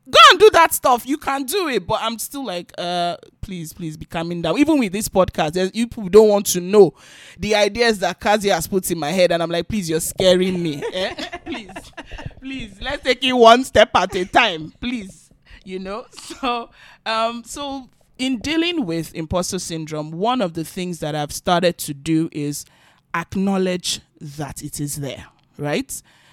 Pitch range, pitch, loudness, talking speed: 170-245 Hz, 190 Hz, -18 LUFS, 185 wpm